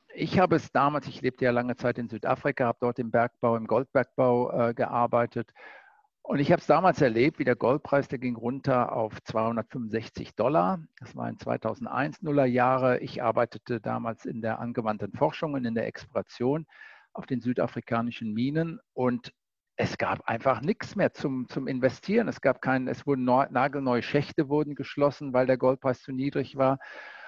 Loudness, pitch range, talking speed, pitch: -28 LUFS, 120-140 Hz, 175 wpm, 125 Hz